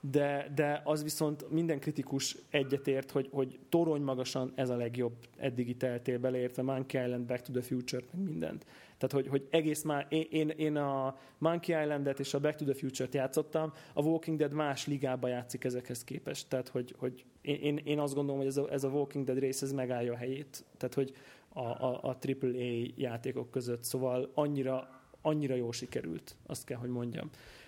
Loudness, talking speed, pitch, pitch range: -35 LUFS, 185 wpm, 135 Hz, 130-145 Hz